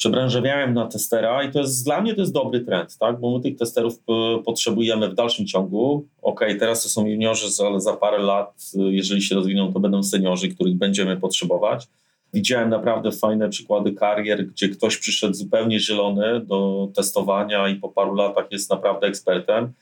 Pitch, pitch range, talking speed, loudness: 105 Hz, 100-120 Hz, 180 wpm, -21 LUFS